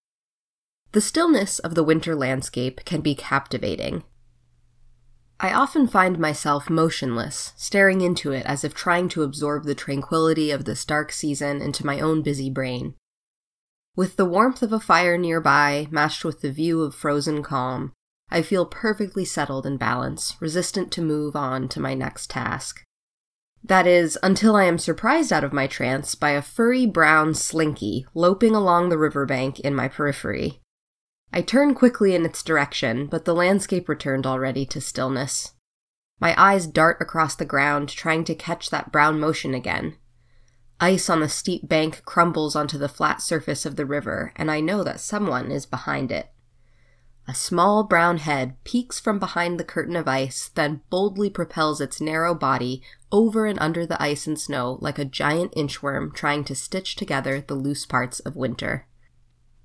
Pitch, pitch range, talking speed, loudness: 155 Hz, 135-175 Hz, 170 wpm, -22 LUFS